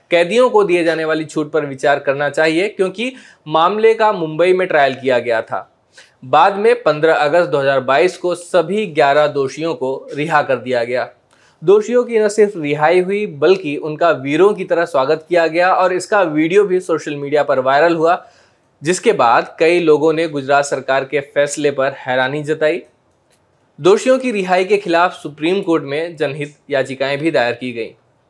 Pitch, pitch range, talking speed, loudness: 160 Hz, 145-185 Hz, 175 wpm, -15 LUFS